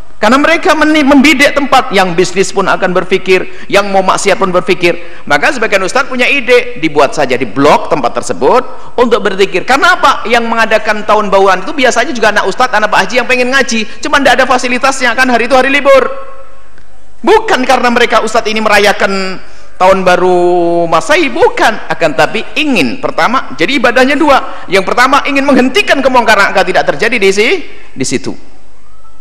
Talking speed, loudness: 170 wpm, -9 LUFS